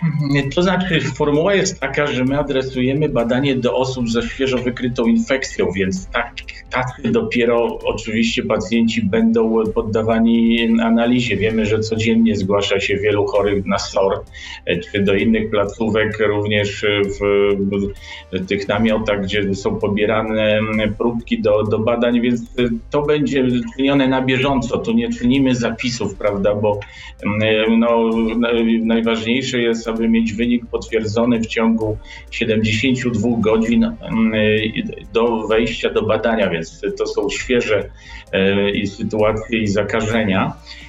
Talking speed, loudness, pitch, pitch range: 125 wpm, -18 LUFS, 115 Hz, 110-130 Hz